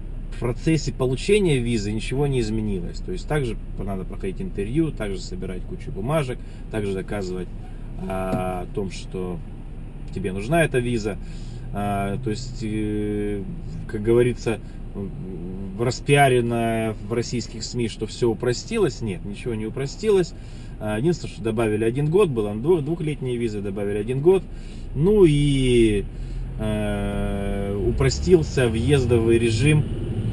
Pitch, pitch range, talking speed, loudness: 115 Hz, 105-130 Hz, 125 wpm, -23 LUFS